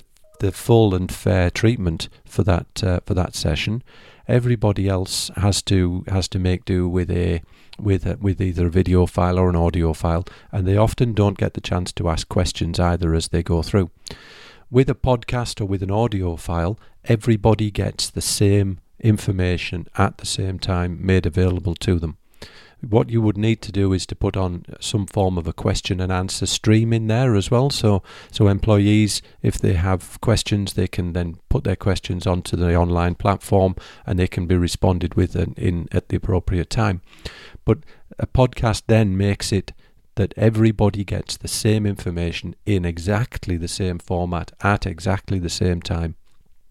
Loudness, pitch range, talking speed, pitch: -21 LUFS, 90-105 Hz, 180 wpm, 95 Hz